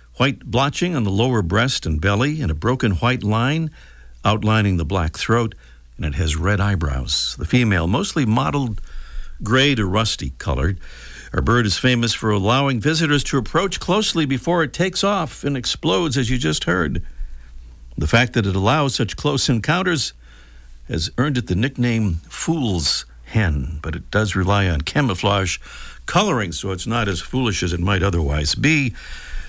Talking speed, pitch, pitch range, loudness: 165 wpm, 110 Hz, 85-130 Hz, -20 LUFS